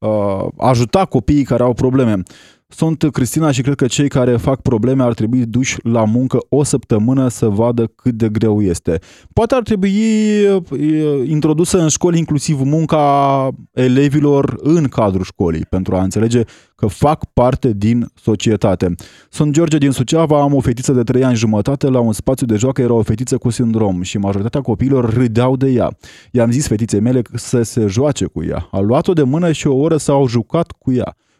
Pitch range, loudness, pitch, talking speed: 115-145 Hz, -15 LUFS, 125 Hz, 180 wpm